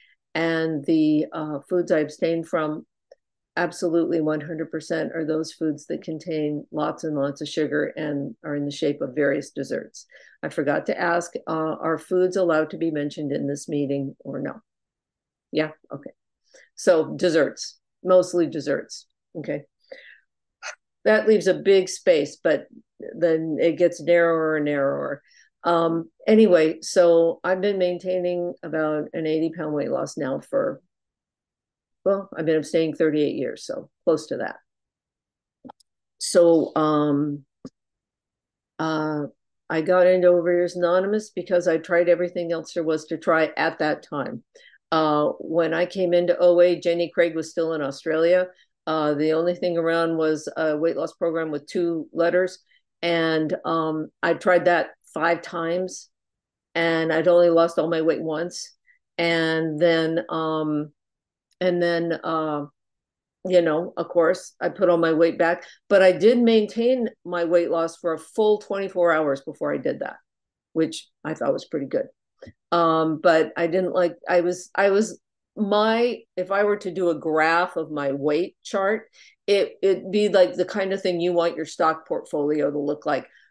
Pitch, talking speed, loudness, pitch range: 165 Hz, 160 wpm, -23 LUFS, 155-180 Hz